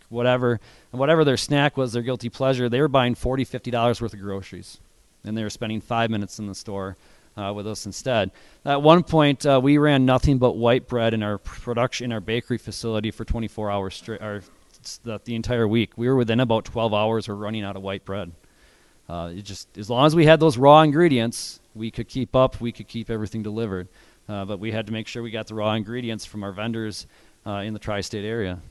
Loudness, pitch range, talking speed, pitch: -22 LUFS, 105-125 Hz, 225 wpm, 115 Hz